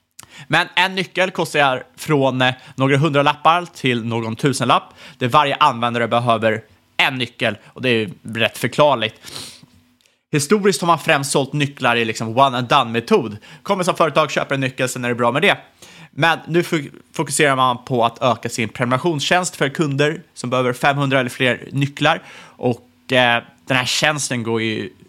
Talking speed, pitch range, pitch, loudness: 170 wpm, 120-160 Hz, 135 Hz, -18 LUFS